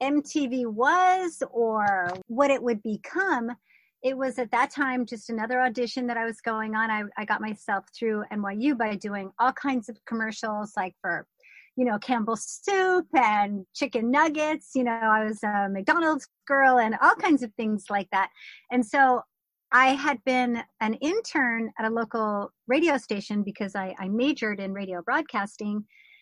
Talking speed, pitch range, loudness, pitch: 170 wpm, 210-270 Hz, -26 LUFS, 235 Hz